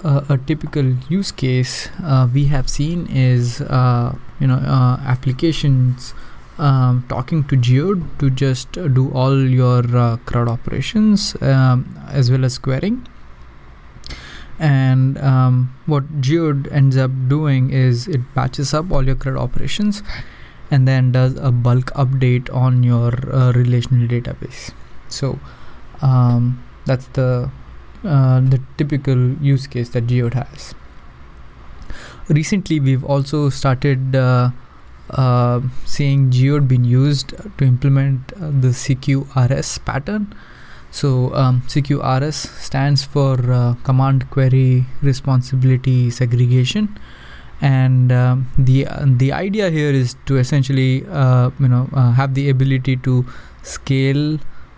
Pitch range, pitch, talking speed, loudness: 125-140 Hz, 130 Hz, 125 wpm, -16 LUFS